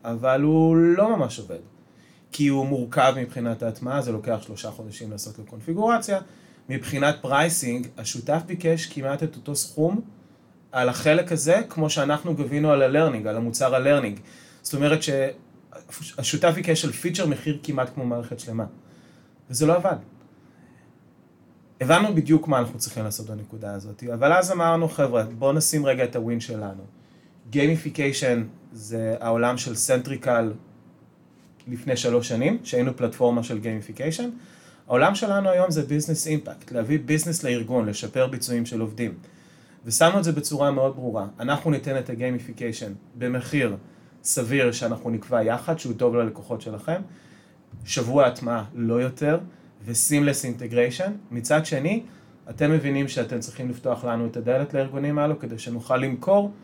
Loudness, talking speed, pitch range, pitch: -24 LUFS, 140 wpm, 120-155 Hz, 130 Hz